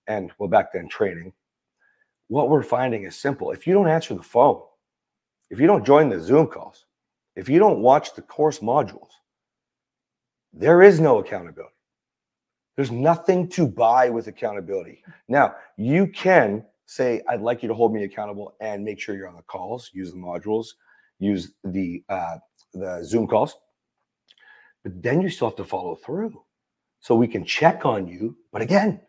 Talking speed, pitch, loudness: 170 wpm, 120 Hz, -21 LUFS